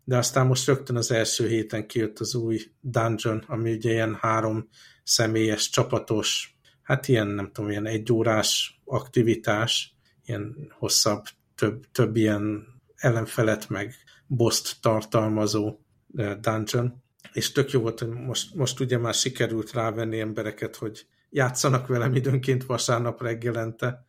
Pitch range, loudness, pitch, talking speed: 110-125 Hz, -25 LUFS, 115 Hz, 130 wpm